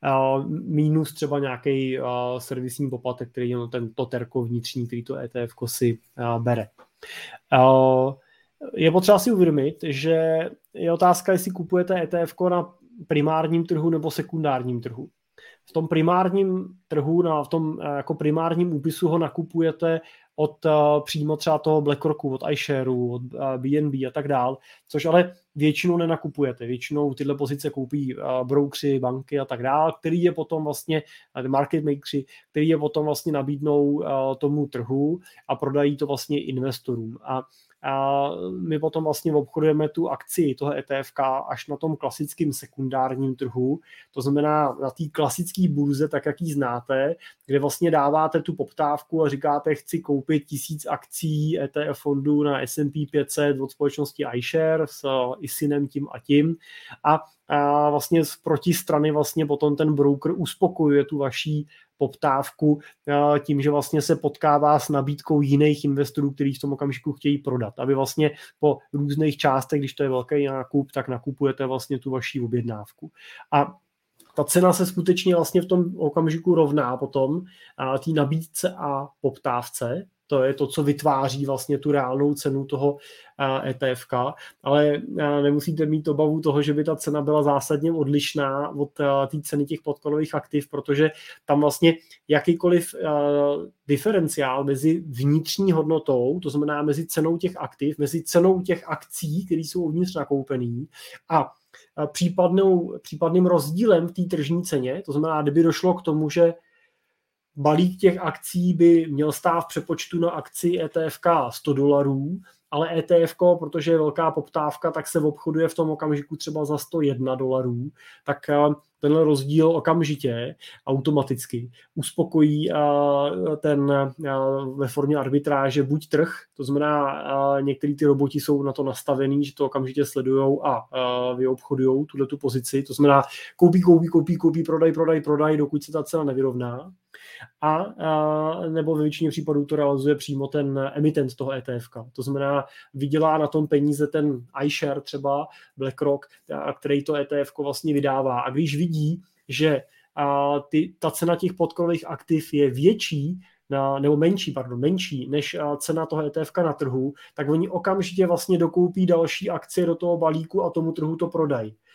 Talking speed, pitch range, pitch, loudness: 150 wpm, 140-160 Hz, 150 Hz, -23 LUFS